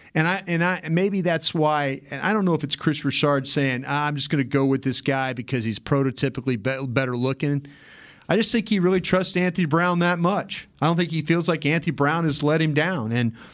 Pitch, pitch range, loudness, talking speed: 150 Hz, 135-175 Hz, -22 LUFS, 235 wpm